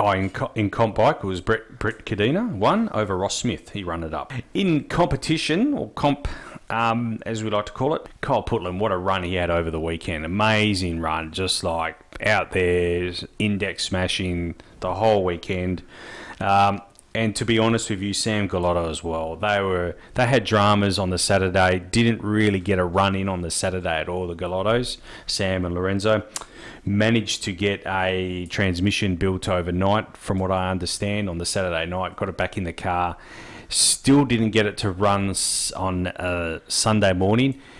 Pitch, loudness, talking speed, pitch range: 95 Hz, -23 LUFS, 180 wpm, 90-110 Hz